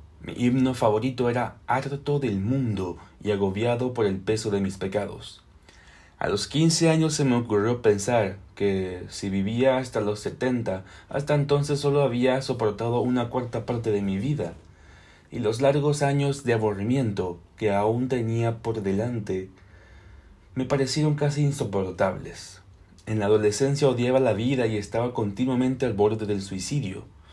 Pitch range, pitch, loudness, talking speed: 95-130 Hz, 115 Hz, -25 LUFS, 150 wpm